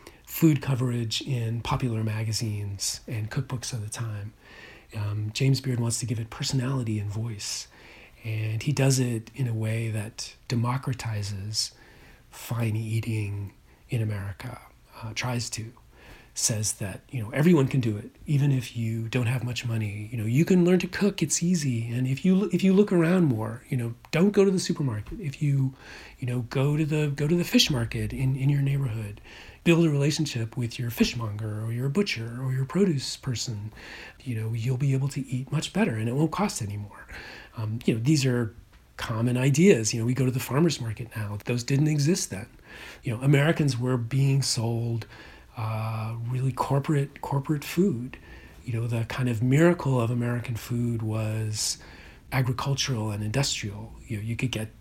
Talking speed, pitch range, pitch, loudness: 185 wpm, 110-140 Hz, 120 Hz, -27 LUFS